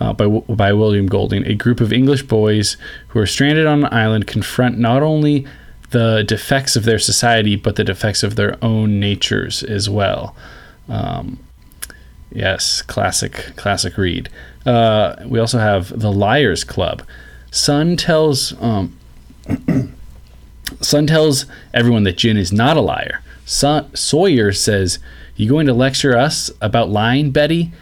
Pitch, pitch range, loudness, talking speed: 110 Hz, 100-135 Hz, -15 LUFS, 145 wpm